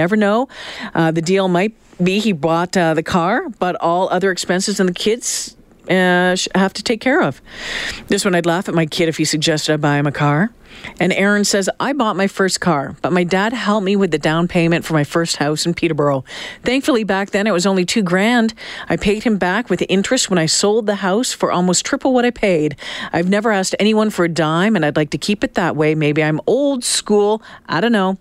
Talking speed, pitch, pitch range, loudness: 235 wpm, 185 Hz, 165-210 Hz, -16 LUFS